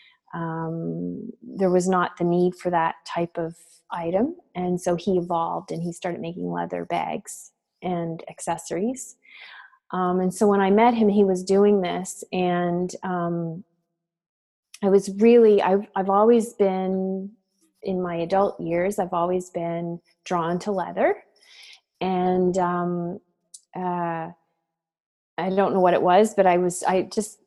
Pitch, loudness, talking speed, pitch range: 180 Hz, -23 LUFS, 150 wpm, 170-195 Hz